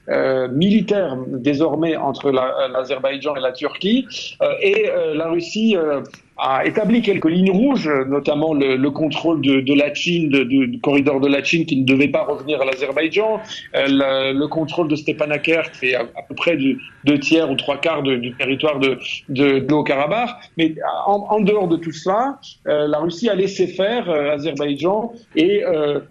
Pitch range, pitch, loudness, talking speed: 140-190 Hz, 150 Hz, -18 LUFS, 195 wpm